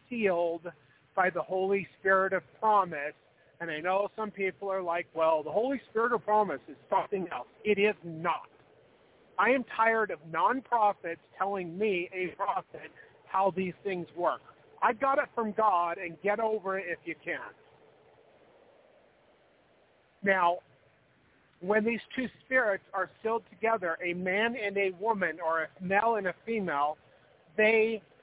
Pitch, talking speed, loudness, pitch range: 195 Hz, 150 wpm, -30 LUFS, 175-220 Hz